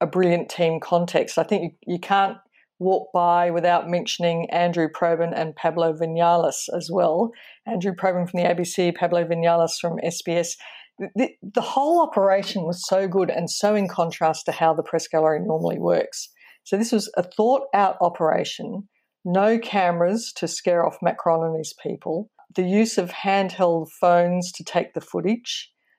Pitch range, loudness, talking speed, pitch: 170-195 Hz, -22 LUFS, 170 wpm, 175 Hz